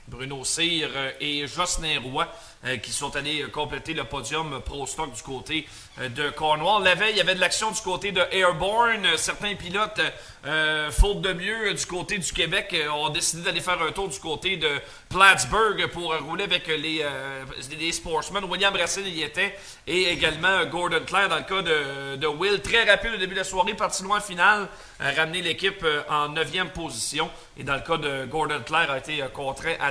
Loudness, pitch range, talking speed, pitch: -24 LUFS, 145-185 Hz, 190 wpm, 160 Hz